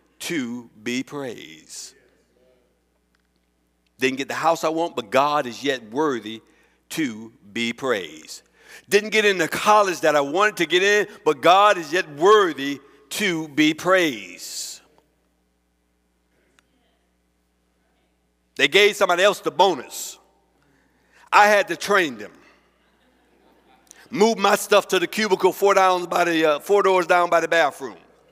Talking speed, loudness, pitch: 135 wpm, -20 LUFS, 160 Hz